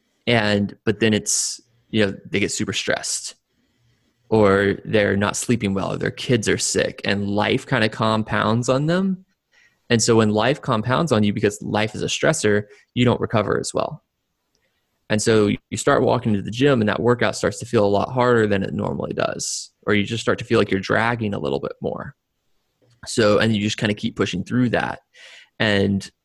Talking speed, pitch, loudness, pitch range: 205 wpm, 110 Hz, -20 LUFS, 105-120 Hz